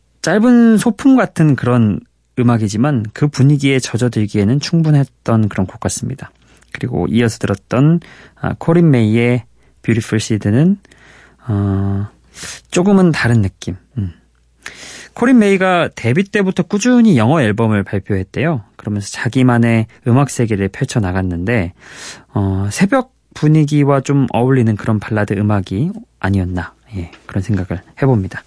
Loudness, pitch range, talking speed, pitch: -15 LUFS, 100-150 Hz, 295 characters per minute, 120 Hz